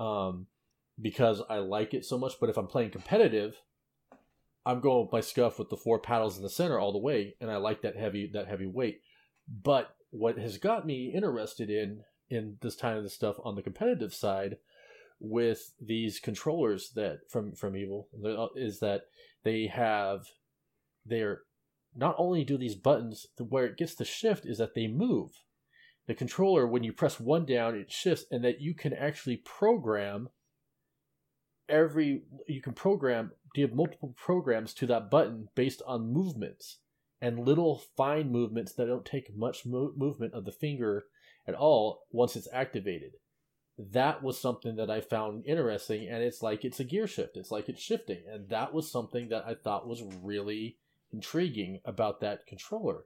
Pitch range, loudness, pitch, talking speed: 110-145 Hz, -32 LUFS, 120 Hz, 175 wpm